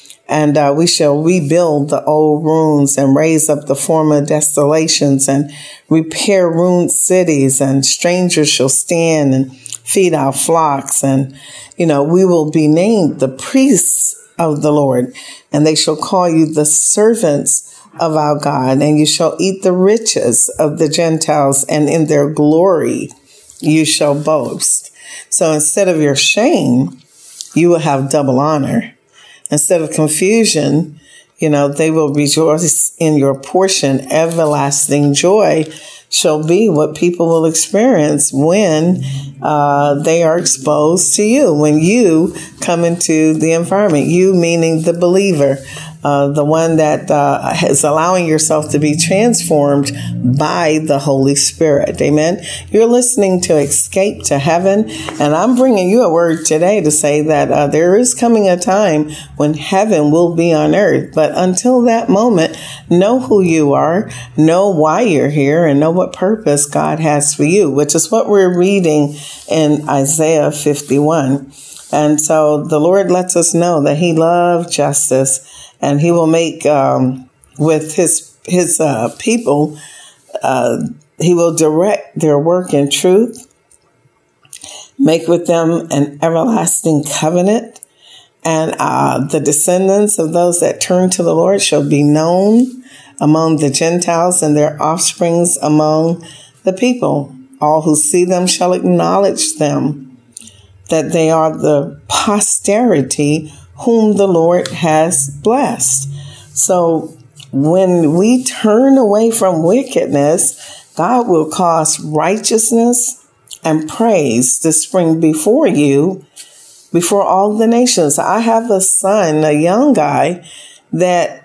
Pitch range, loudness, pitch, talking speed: 145-180 Hz, -12 LUFS, 160 Hz, 140 wpm